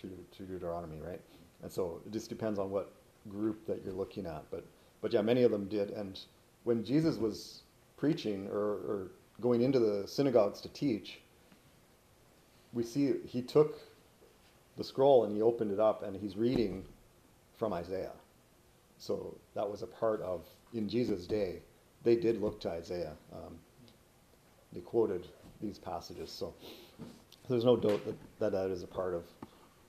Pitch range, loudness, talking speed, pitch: 95-120 Hz, -34 LUFS, 165 wpm, 110 Hz